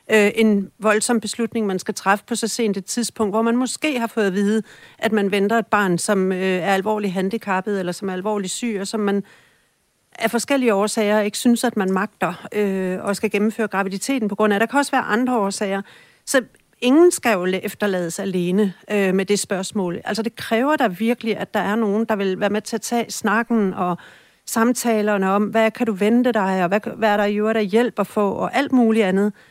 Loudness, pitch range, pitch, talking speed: -20 LUFS, 195-230 Hz, 210 Hz, 220 wpm